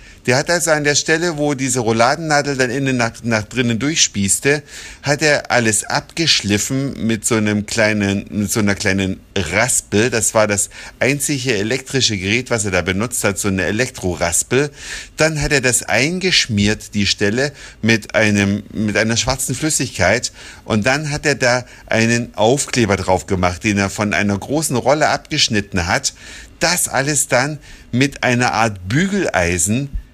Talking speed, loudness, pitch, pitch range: 155 wpm, -16 LUFS, 115 Hz, 100-140 Hz